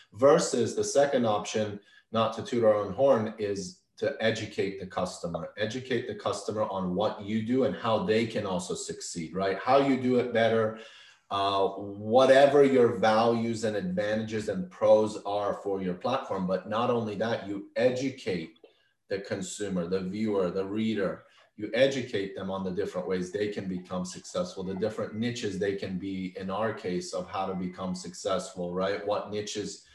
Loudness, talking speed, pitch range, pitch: -29 LUFS, 170 wpm, 95-115 Hz, 105 Hz